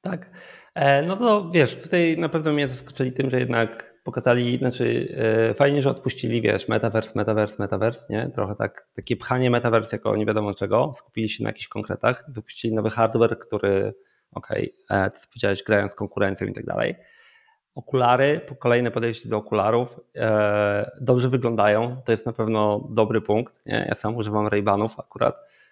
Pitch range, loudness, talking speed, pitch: 110-135 Hz, -23 LUFS, 165 wpm, 115 Hz